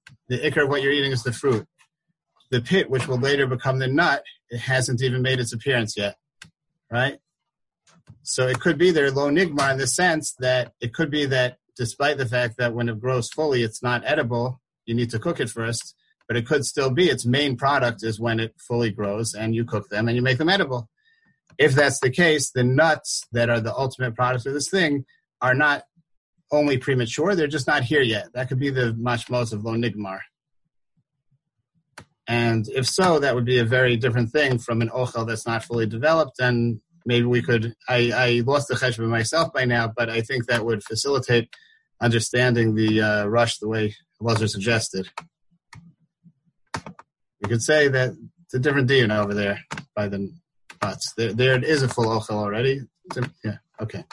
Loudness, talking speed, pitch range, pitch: -22 LUFS, 195 wpm, 115-140 Hz, 125 Hz